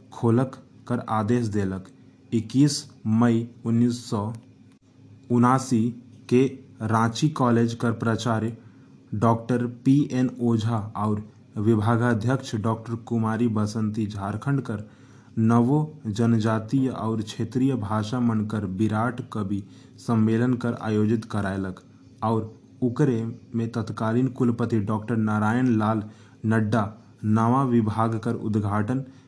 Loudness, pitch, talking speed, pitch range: -25 LUFS, 115 Hz, 100 wpm, 110-125 Hz